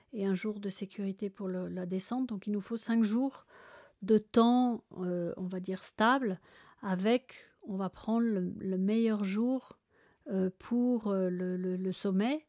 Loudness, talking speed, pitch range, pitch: -33 LUFS, 175 wpm, 190-235 Hz, 205 Hz